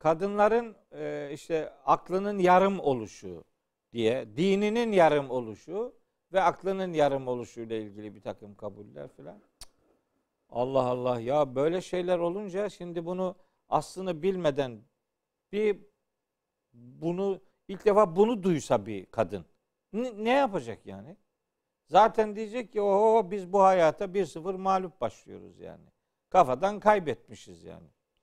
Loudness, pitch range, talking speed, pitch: -28 LUFS, 125-200 Hz, 115 wpm, 175 Hz